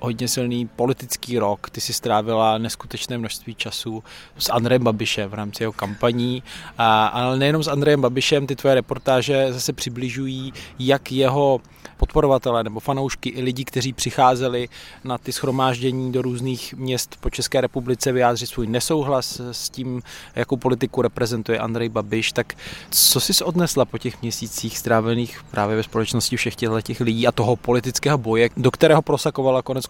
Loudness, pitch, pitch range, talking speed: -21 LUFS, 125 Hz, 115-130 Hz, 155 wpm